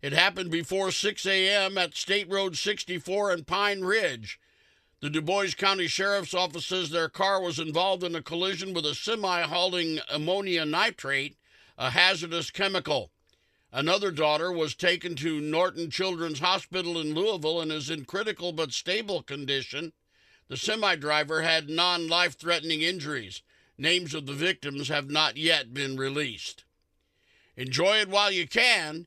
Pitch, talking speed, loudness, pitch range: 175 Hz, 155 wpm, -27 LUFS, 155-190 Hz